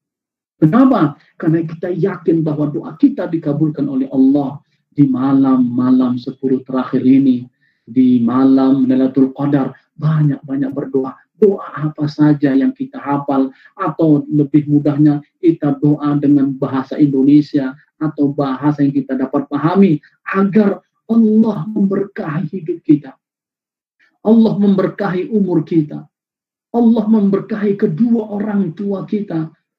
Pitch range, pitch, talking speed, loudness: 140-195 Hz, 150 Hz, 115 wpm, -15 LUFS